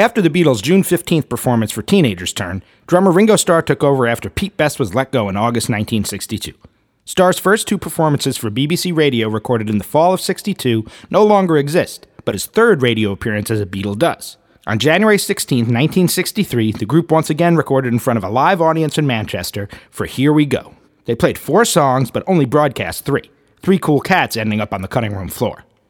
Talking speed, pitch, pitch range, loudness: 200 wpm, 135 Hz, 110-175 Hz, -16 LUFS